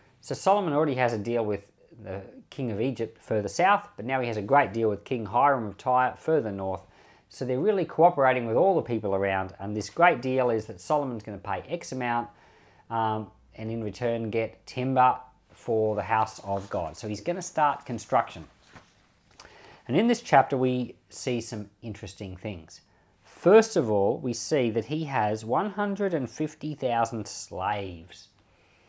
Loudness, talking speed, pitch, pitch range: -27 LUFS, 175 wpm, 115 Hz, 105-140 Hz